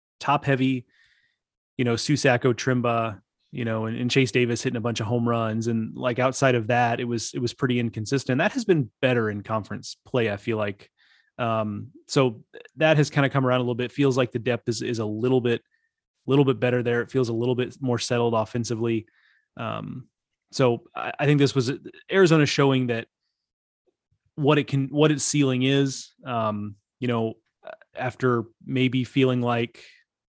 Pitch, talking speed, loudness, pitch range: 125 Hz, 190 wpm, -24 LUFS, 115-135 Hz